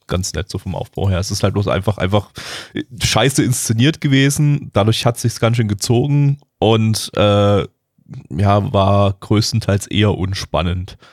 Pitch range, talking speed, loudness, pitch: 100-130 Hz, 150 wpm, -16 LUFS, 105 Hz